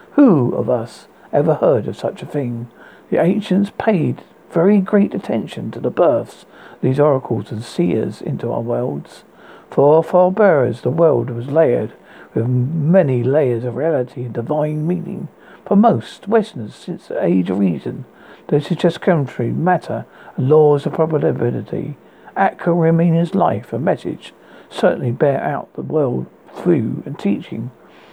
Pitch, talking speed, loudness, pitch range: 155 Hz, 150 wpm, -17 LUFS, 125-180 Hz